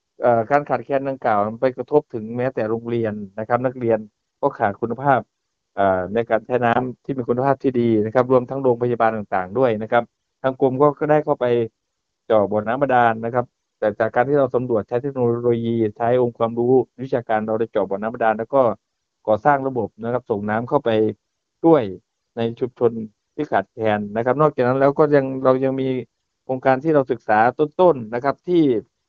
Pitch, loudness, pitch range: 120 Hz, -20 LUFS, 110-135 Hz